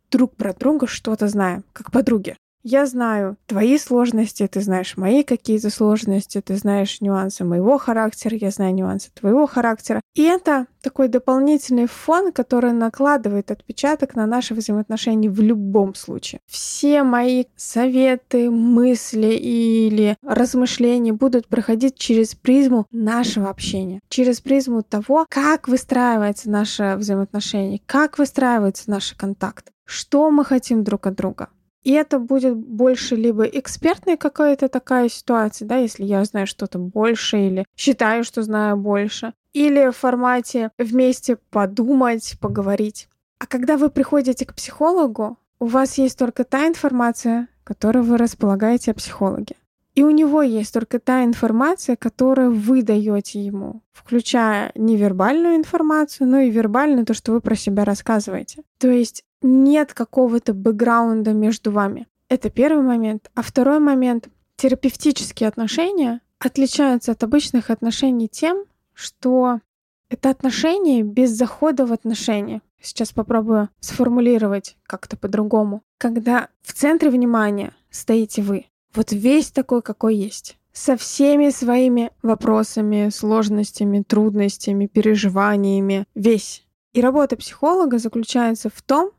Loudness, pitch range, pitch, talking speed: -19 LUFS, 215-260 Hz, 235 Hz, 130 wpm